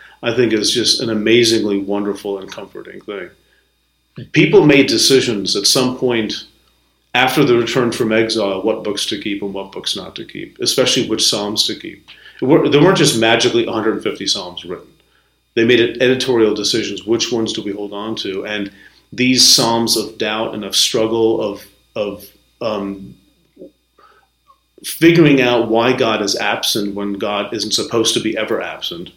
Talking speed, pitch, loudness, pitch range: 165 wpm, 110 Hz, -15 LUFS, 100-120 Hz